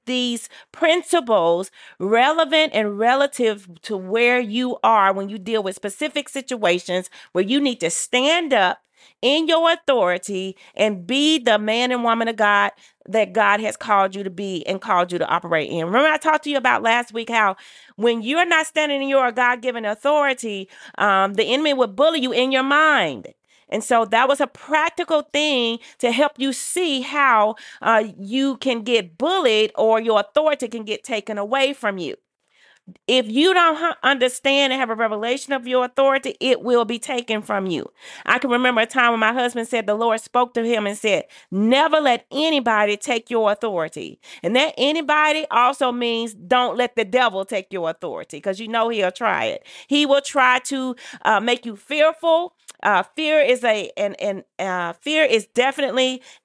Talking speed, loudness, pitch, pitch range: 185 wpm, -19 LUFS, 245 Hz, 215-275 Hz